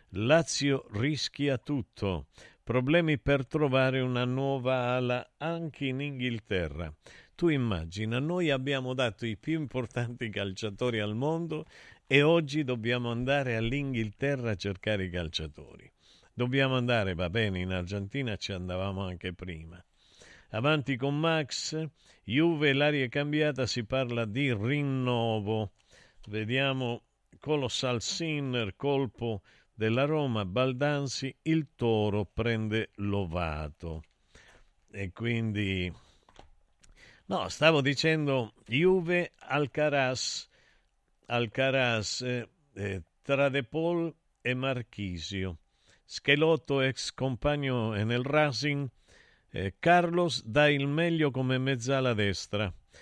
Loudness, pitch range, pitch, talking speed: -30 LUFS, 105-145 Hz, 125 Hz, 100 wpm